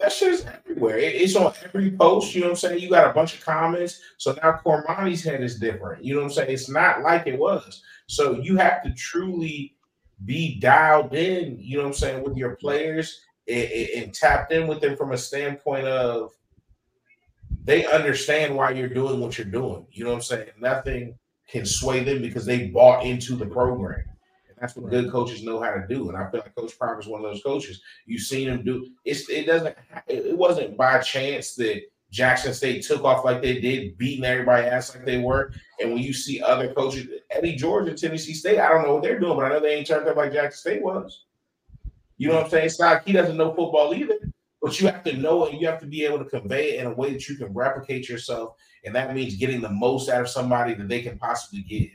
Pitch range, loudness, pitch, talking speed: 125-160 Hz, -23 LUFS, 135 Hz, 240 wpm